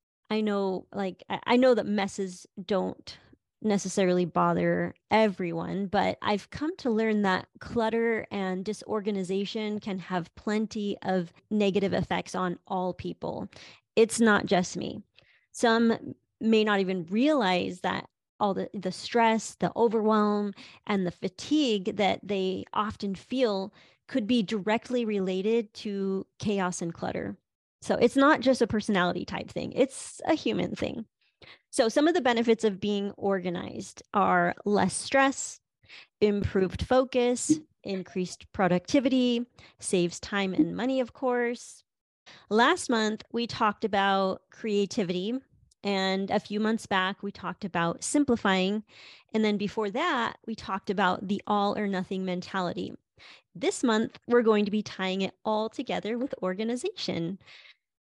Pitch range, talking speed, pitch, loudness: 190-230 Hz, 135 wpm, 210 Hz, -28 LUFS